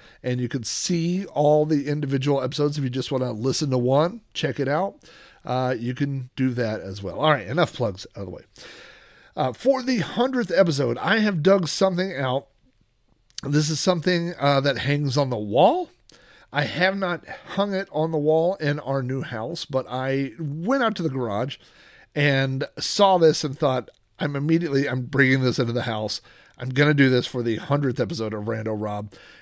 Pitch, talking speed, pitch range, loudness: 140 Hz, 195 wpm, 125-165 Hz, -23 LUFS